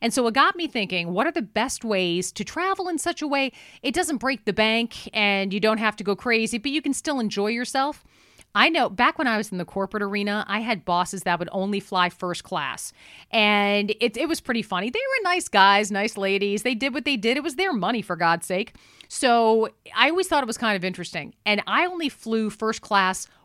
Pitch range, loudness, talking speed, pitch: 200-270 Hz, -23 LUFS, 240 wpm, 220 Hz